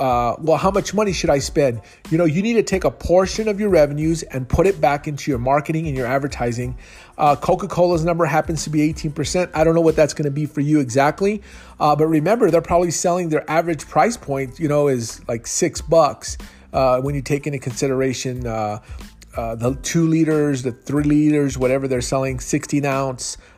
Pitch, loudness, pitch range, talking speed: 145 Hz, -19 LUFS, 130-165 Hz, 210 wpm